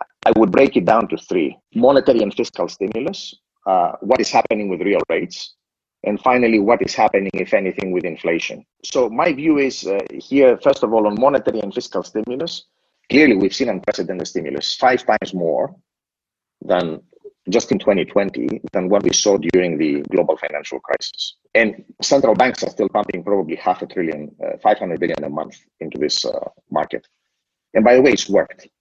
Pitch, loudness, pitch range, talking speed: 110 Hz, -18 LUFS, 90-135 Hz, 180 wpm